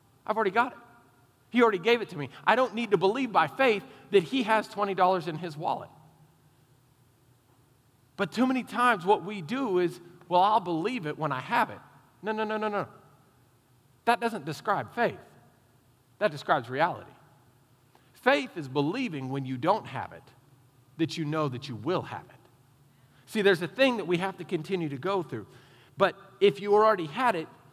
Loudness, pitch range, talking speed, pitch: -28 LUFS, 130-205 Hz, 185 wpm, 160 Hz